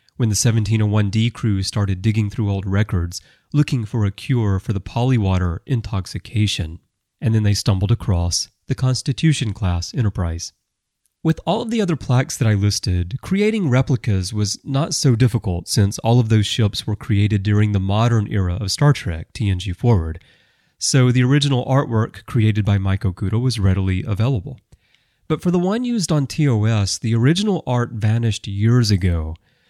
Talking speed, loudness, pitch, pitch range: 165 wpm, -19 LUFS, 110 Hz, 100-130 Hz